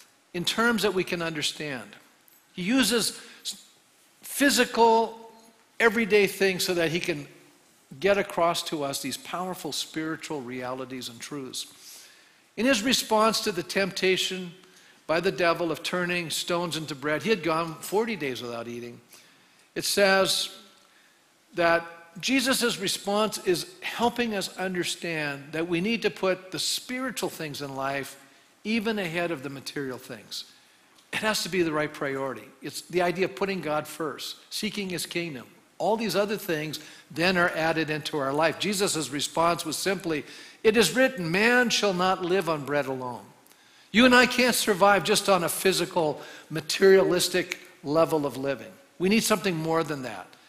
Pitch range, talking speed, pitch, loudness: 155-205 Hz, 155 wpm, 175 Hz, -26 LUFS